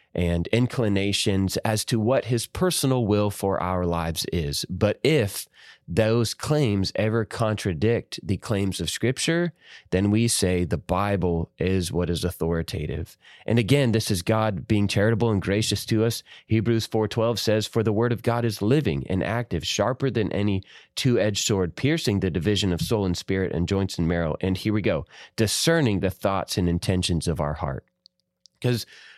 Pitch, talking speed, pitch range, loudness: 105 Hz, 170 wpm, 90-115 Hz, -24 LUFS